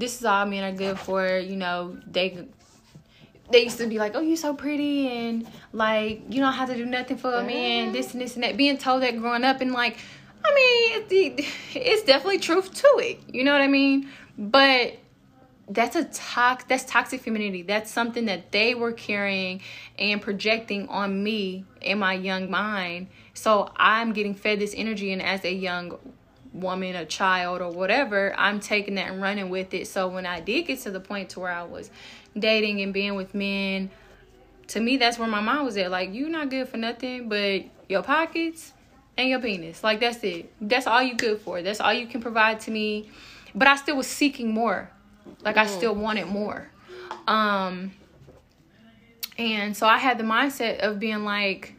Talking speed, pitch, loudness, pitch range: 200 wpm, 220 Hz, -24 LUFS, 195-250 Hz